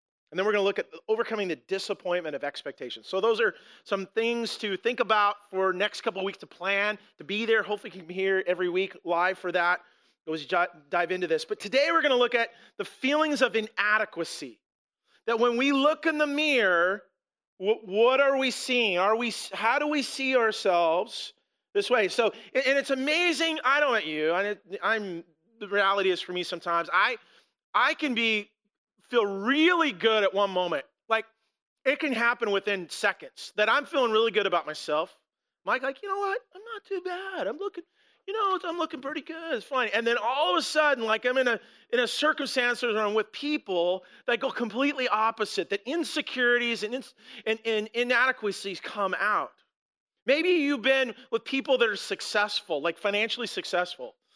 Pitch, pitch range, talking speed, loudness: 225 Hz, 195-270 Hz, 190 wpm, -27 LUFS